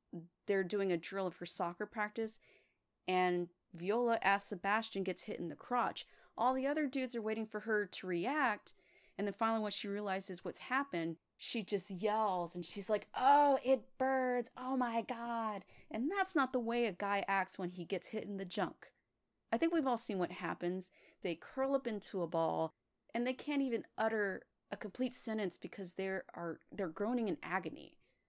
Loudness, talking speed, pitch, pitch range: -36 LUFS, 190 wpm, 210 Hz, 185-240 Hz